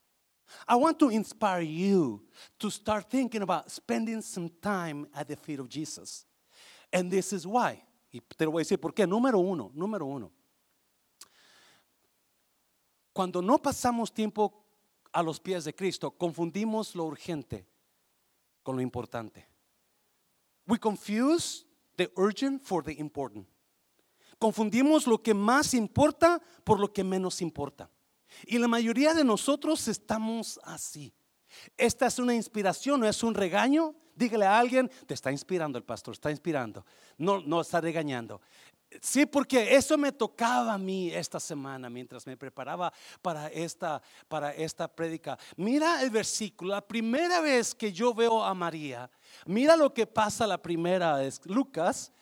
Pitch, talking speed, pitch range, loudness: 200 Hz, 150 wpm, 160-235 Hz, -29 LUFS